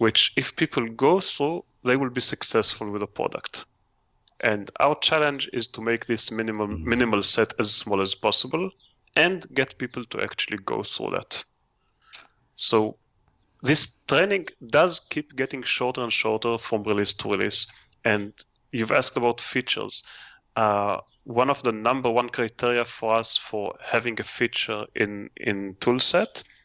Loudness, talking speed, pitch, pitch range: -23 LUFS, 155 wpm, 115 Hz, 105-125 Hz